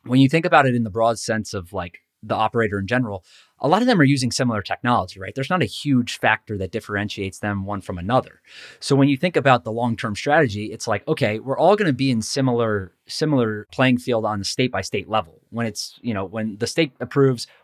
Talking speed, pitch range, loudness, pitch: 240 wpm, 105-135 Hz, -21 LUFS, 115 Hz